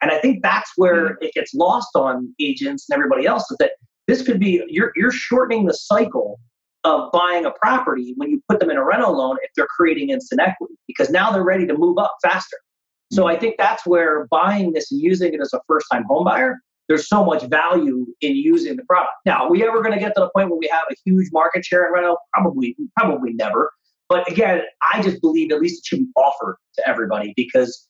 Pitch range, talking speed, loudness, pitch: 165-260 Hz, 230 wpm, -18 LUFS, 195 Hz